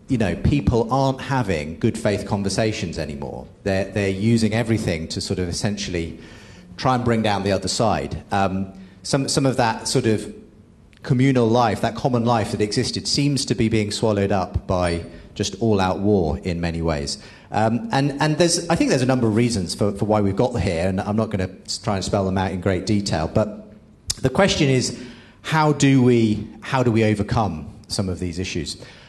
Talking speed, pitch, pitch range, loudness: 200 wpm, 105 Hz, 95-120 Hz, -21 LUFS